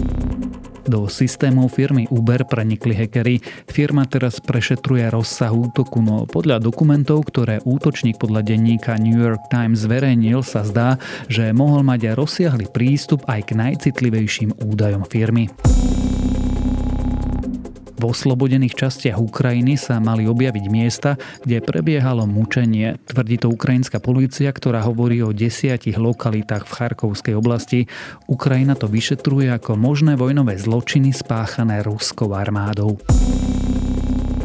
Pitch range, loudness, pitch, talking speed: 110-130 Hz, -18 LUFS, 120 Hz, 115 wpm